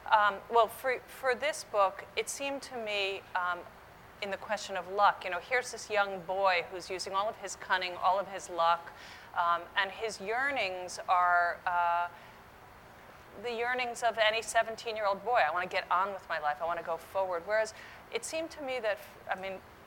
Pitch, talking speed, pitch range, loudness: 195 Hz, 200 wpm, 180-230 Hz, -32 LUFS